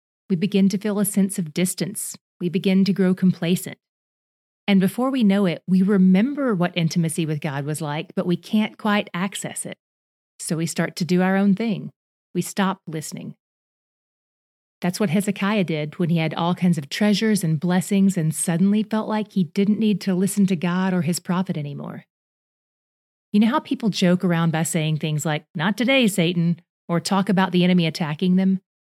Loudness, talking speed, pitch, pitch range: -21 LUFS, 190 wpm, 185 Hz, 170-200 Hz